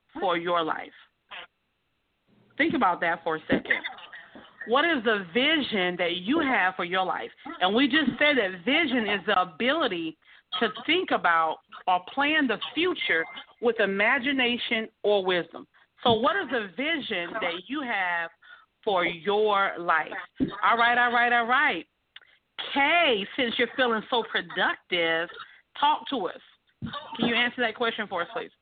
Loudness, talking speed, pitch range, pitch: -25 LUFS, 155 wpm, 185-275 Hz, 235 Hz